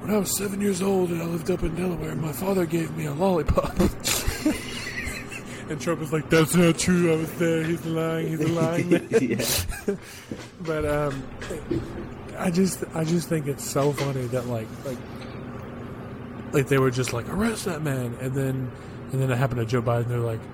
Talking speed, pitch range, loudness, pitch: 185 wpm, 125-170 Hz, -25 LUFS, 150 Hz